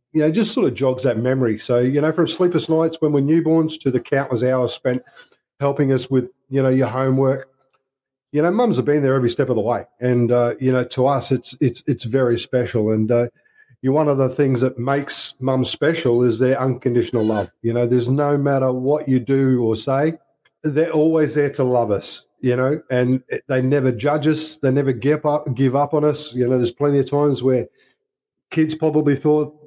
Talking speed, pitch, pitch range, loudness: 220 wpm, 135 Hz, 125-150 Hz, -19 LUFS